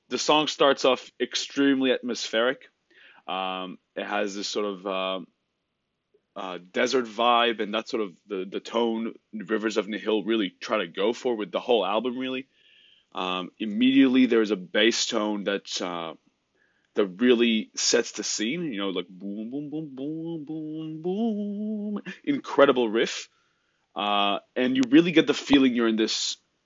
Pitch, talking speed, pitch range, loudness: 120 Hz, 160 wpm, 105-150 Hz, -25 LUFS